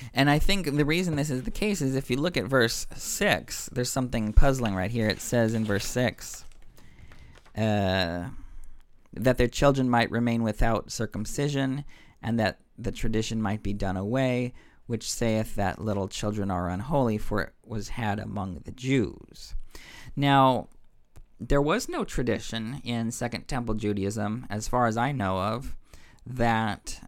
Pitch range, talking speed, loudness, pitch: 105-130 Hz, 160 wpm, -27 LUFS, 115 Hz